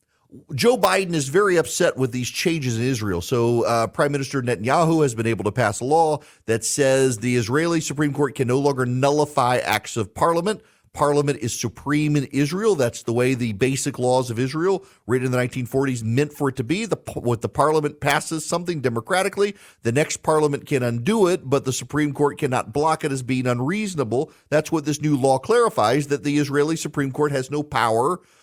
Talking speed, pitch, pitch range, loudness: 200 wpm, 140 Hz, 125-155 Hz, -21 LUFS